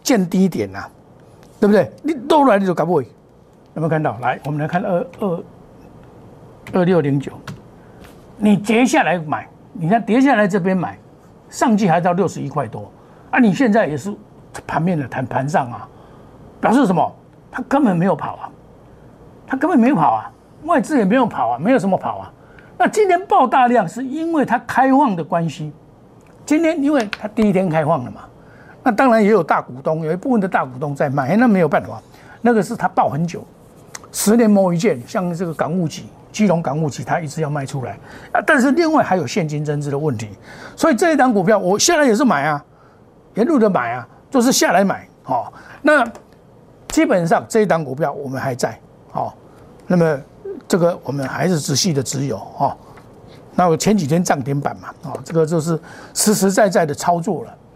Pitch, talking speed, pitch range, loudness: 185 Hz, 280 characters per minute, 155-240 Hz, -17 LUFS